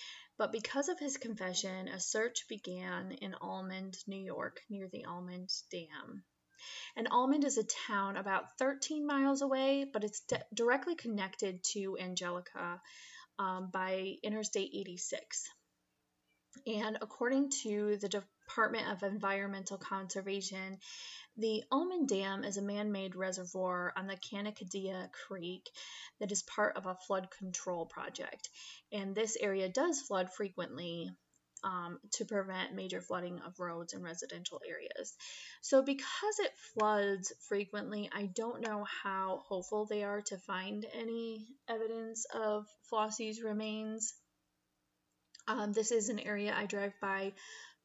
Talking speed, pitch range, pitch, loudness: 135 wpm, 190-225 Hz, 205 Hz, -38 LUFS